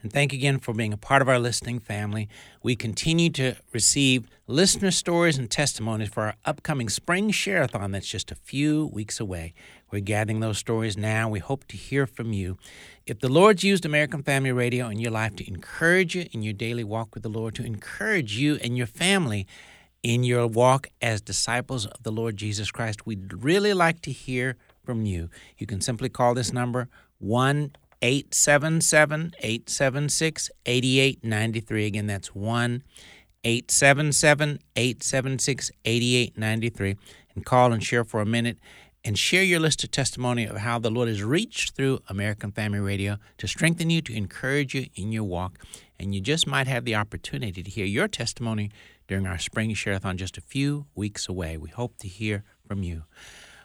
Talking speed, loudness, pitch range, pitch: 175 wpm, -25 LUFS, 105-135 Hz, 120 Hz